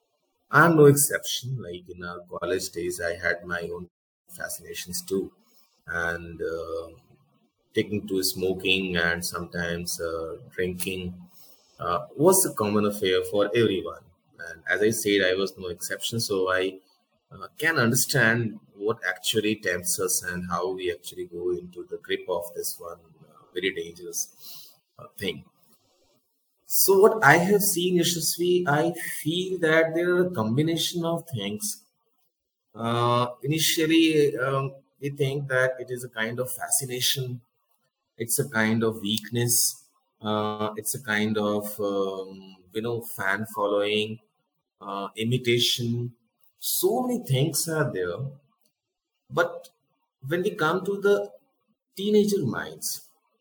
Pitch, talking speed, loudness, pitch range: 120 Hz, 135 wpm, -25 LUFS, 100-165 Hz